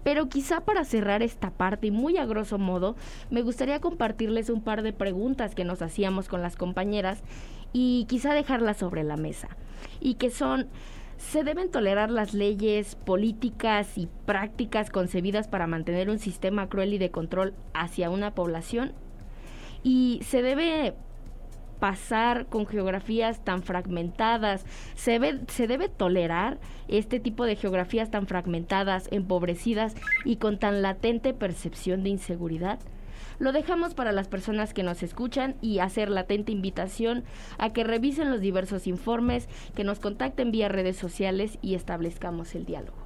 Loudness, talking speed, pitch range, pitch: -28 LUFS, 150 wpm, 190-240 Hz, 210 Hz